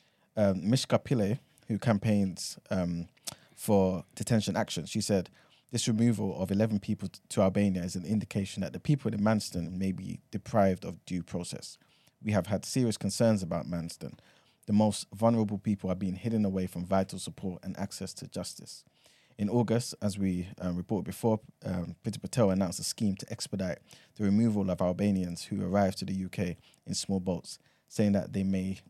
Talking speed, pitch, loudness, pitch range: 175 wpm, 100 Hz, -31 LUFS, 95-110 Hz